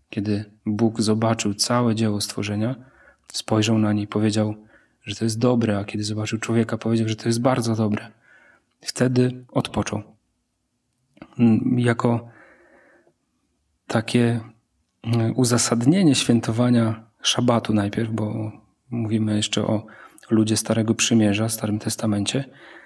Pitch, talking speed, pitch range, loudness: 110 Hz, 110 wpm, 105-120 Hz, -22 LUFS